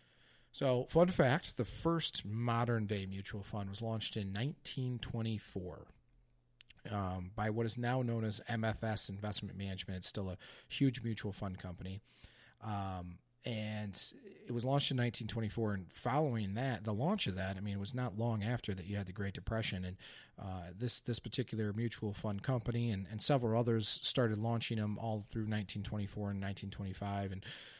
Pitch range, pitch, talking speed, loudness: 100-120 Hz, 110 Hz, 165 wpm, -38 LUFS